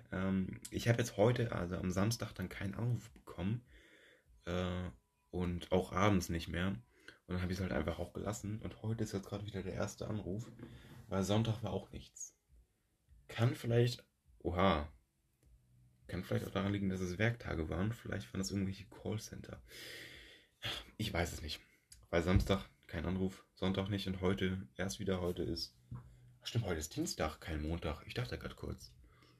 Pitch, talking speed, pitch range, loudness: 95 Hz, 170 wpm, 85-105 Hz, -39 LUFS